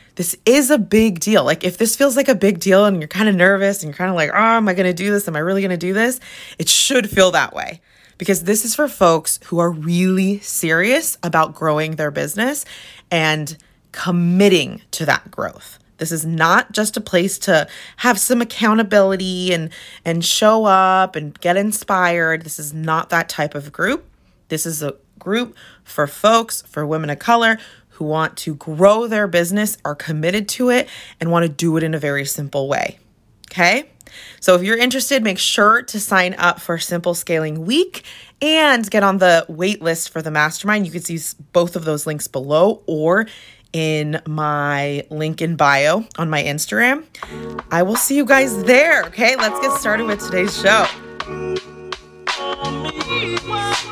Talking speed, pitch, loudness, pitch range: 185 wpm, 180 Hz, -17 LUFS, 160-215 Hz